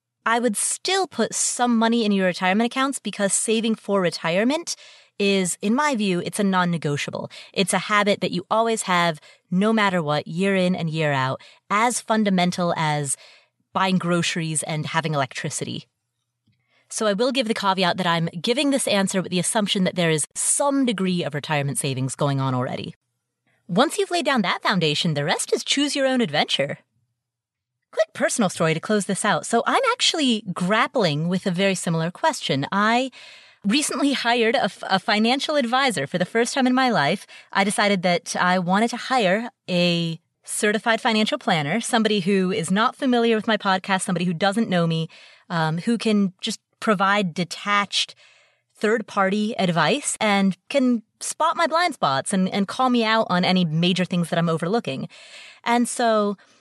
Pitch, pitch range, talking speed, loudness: 200 Hz, 170-235 Hz, 175 wpm, -21 LUFS